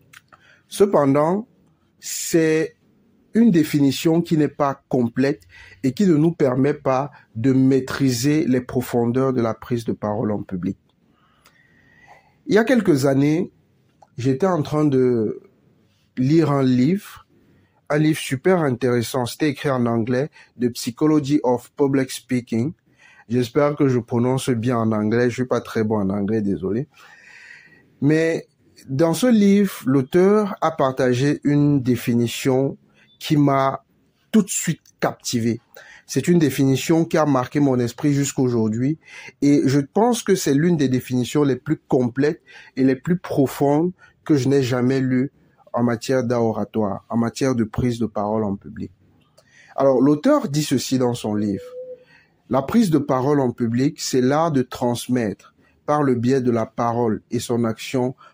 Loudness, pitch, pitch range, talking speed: -20 LUFS, 135 Hz, 120-150 Hz, 150 wpm